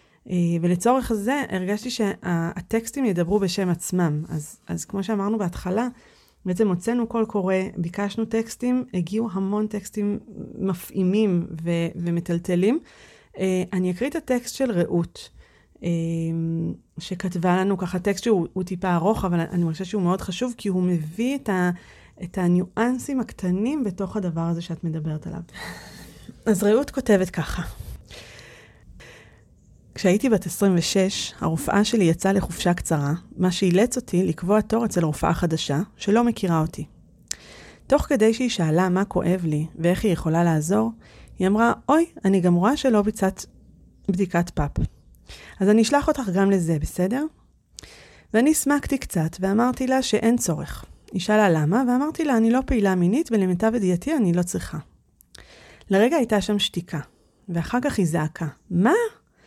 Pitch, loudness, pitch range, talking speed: 190 Hz, -23 LUFS, 175-225 Hz, 140 wpm